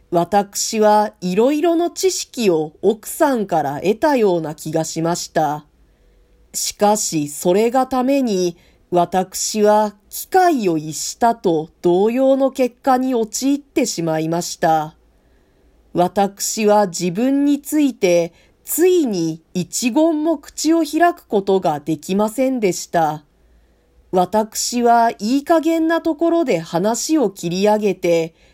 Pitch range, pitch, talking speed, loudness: 175-265 Hz, 210 Hz, 225 characters per minute, -18 LUFS